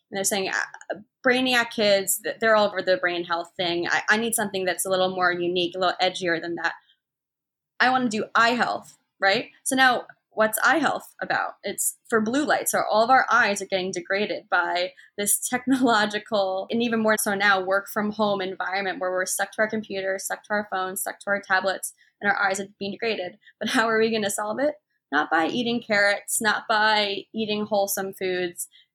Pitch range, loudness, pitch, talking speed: 190-220 Hz, -23 LUFS, 200 Hz, 205 wpm